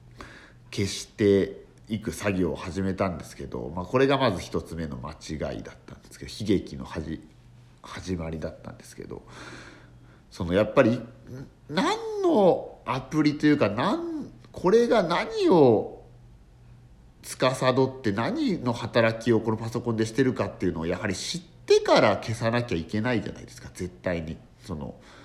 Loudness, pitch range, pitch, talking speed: -25 LUFS, 90-130 Hz, 115 Hz, 300 characters per minute